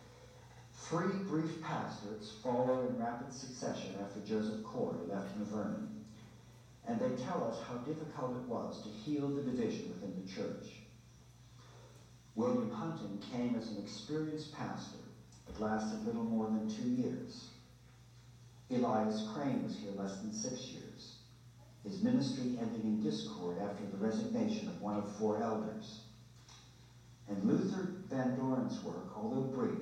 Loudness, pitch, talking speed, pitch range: -39 LUFS, 120 Hz, 135 wpm, 110-130 Hz